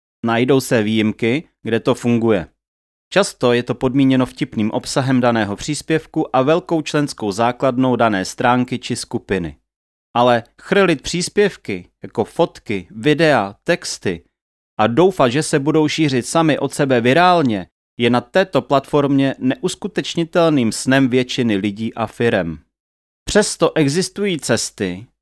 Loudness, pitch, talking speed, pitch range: -17 LUFS, 130 Hz, 125 wpm, 110-155 Hz